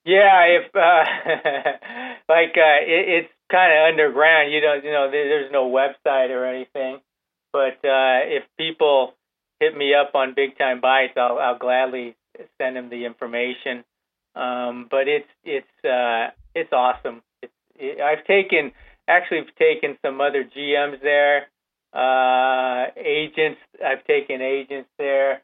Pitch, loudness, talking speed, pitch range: 140 Hz, -19 LUFS, 145 wpm, 130-160 Hz